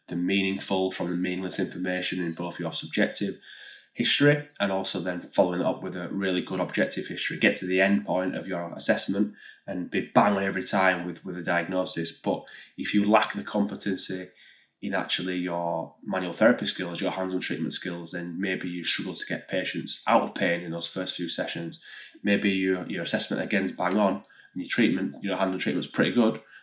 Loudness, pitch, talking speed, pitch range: -27 LUFS, 90 Hz, 205 wpm, 85-95 Hz